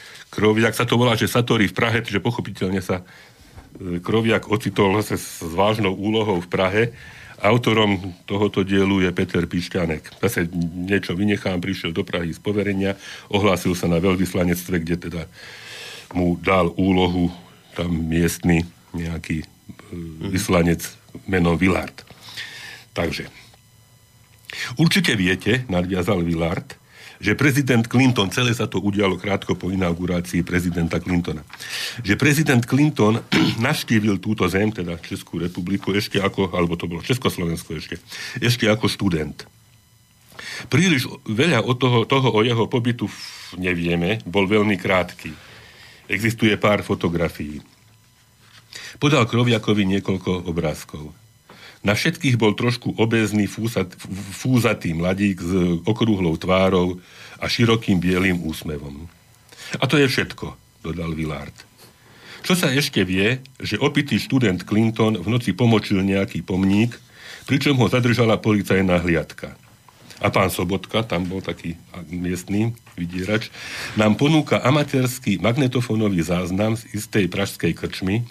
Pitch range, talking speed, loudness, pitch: 90-115 Hz, 120 wpm, -21 LUFS, 100 Hz